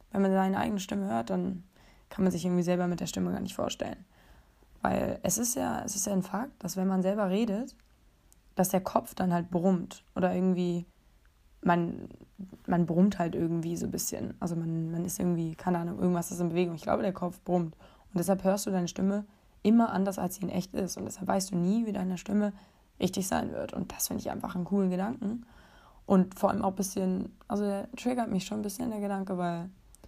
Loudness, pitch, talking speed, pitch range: -31 LUFS, 190 Hz, 225 wpm, 180-200 Hz